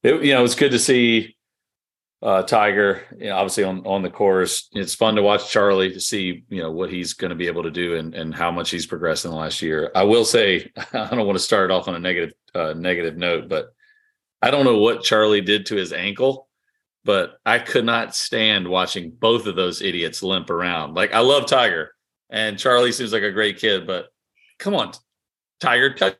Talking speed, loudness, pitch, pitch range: 220 wpm, -20 LUFS, 105 Hz, 90-120 Hz